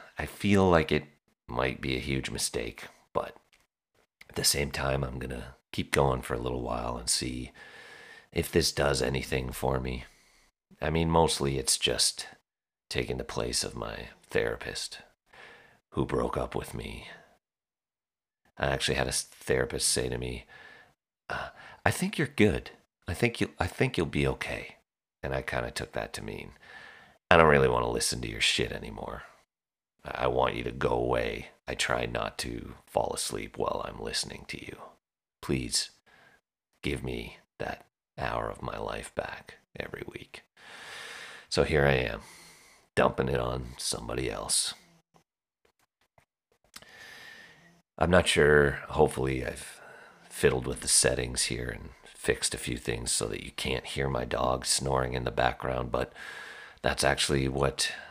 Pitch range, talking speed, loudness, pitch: 60-70 Hz, 155 wpm, -29 LUFS, 65 Hz